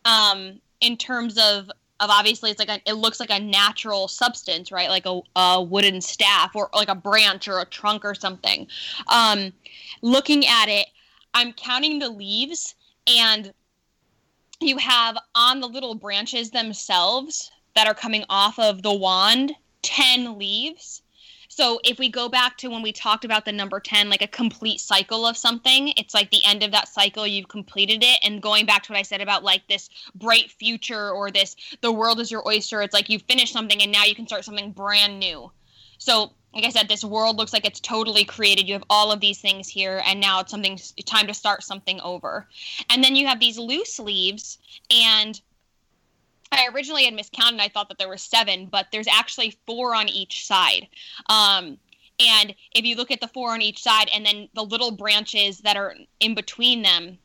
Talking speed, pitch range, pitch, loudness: 200 wpm, 200-235 Hz, 215 Hz, -19 LUFS